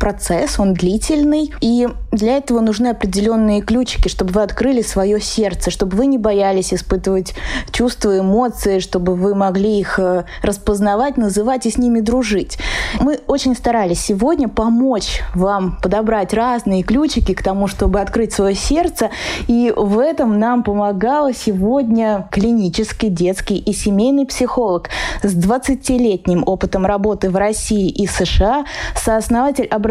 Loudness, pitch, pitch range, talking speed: -16 LUFS, 215 Hz, 195-245 Hz, 135 wpm